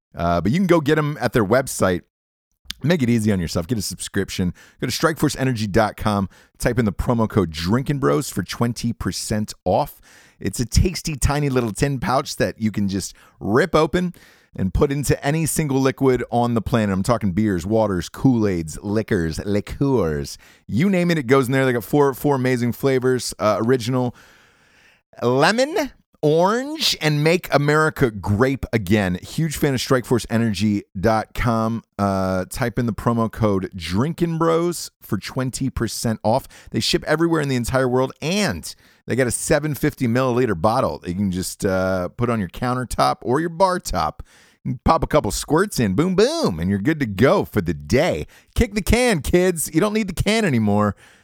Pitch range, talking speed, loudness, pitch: 100-145 Hz, 175 wpm, -20 LUFS, 120 Hz